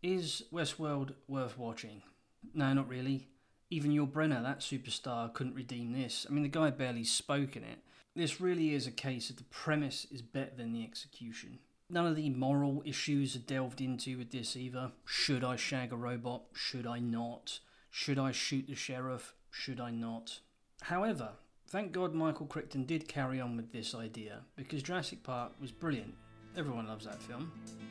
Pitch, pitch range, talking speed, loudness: 130 Hz, 120-145 Hz, 180 wpm, -38 LUFS